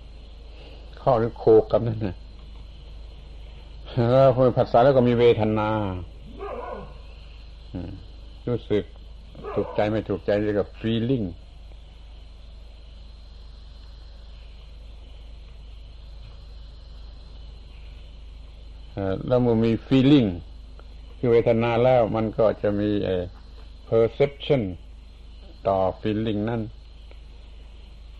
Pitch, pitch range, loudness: 75 Hz, 70-105 Hz, -22 LUFS